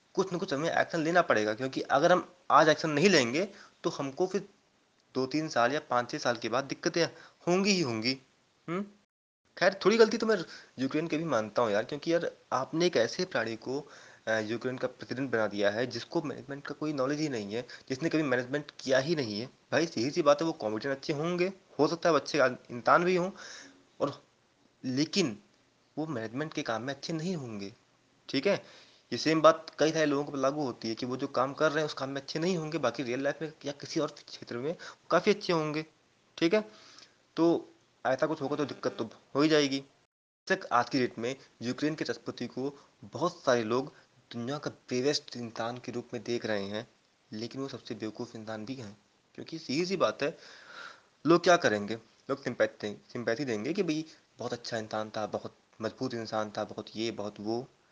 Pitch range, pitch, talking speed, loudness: 120-160 Hz, 140 Hz, 205 wpm, -31 LUFS